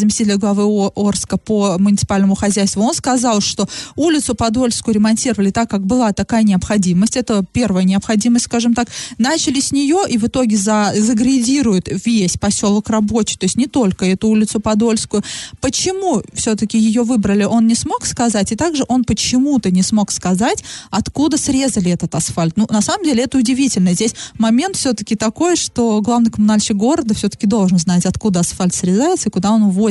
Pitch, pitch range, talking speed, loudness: 220 Hz, 200-245 Hz, 165 wpm, -15 LUFS